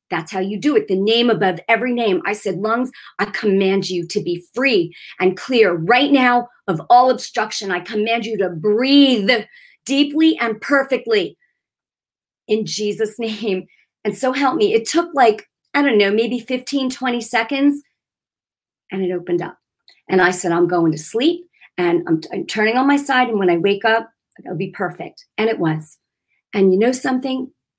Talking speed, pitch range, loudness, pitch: 185 wpm, 190-260 Hz, -18 LUFS, 225 Hz